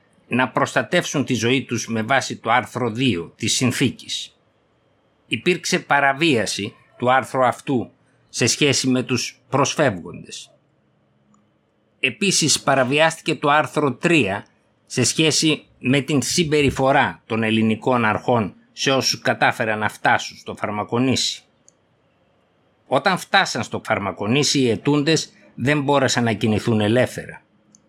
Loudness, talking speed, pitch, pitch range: -19 LUFS, 115 wpm, 130 Hz, 115-145 Hz